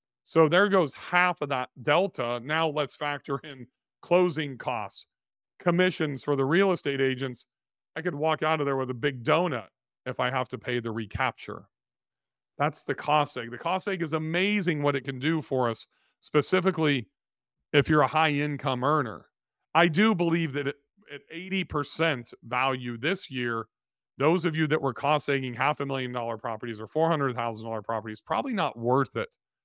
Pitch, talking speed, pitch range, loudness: 145 Hz, 180 wpm, 125-160 Hz, -27 LUFS